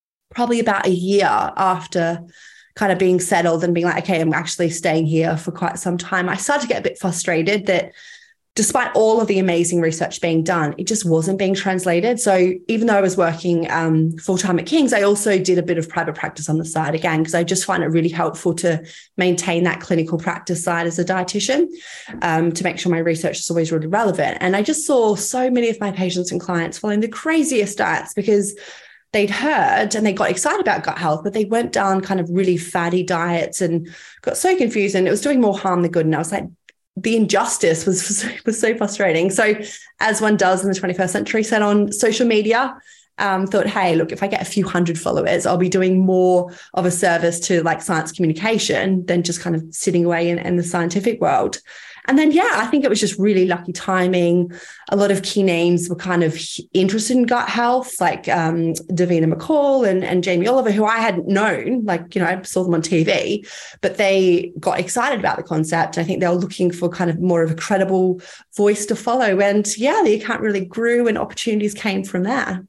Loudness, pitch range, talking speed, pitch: -18 LUFS, 170-210 Hz, 220 wpm, 185 Hz